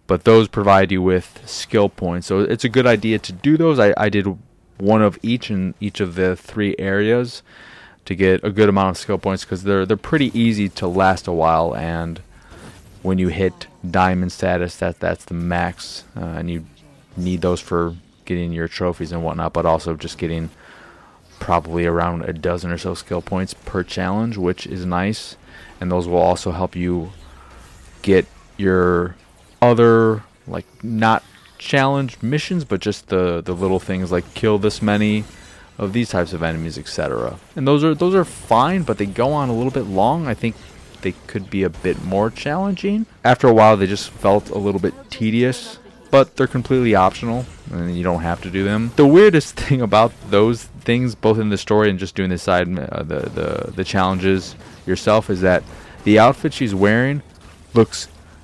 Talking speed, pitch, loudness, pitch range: 190 wpm, 95 Hz, -18 LUFS, 90-110 Hz